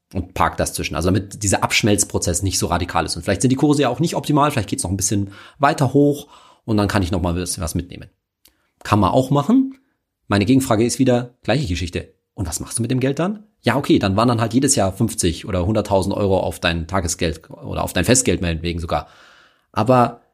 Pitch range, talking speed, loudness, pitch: 90-130 Hz, 225 wpm, -19 LUFS, 105 Hz